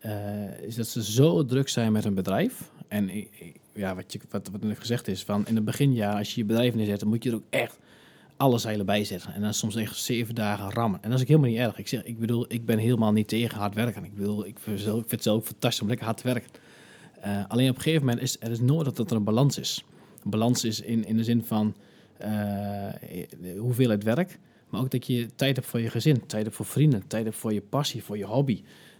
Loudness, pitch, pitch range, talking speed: -27 LUFS, 115 Hz, 105-120 Hz, 265 wpm